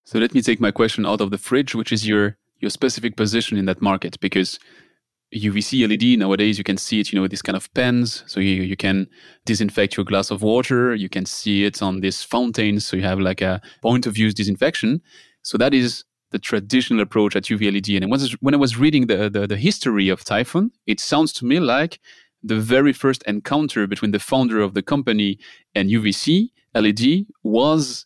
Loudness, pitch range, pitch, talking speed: -20 LUFS, 100-125 Hz, 105 Hz, 210 wpm